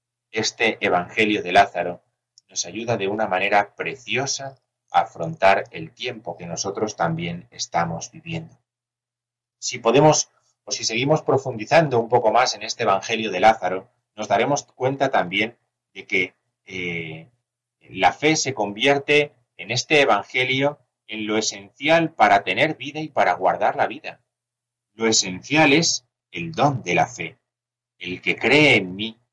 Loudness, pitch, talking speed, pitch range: -21 LUFS, 120 Hz, 145 wpm, 100-135 Hz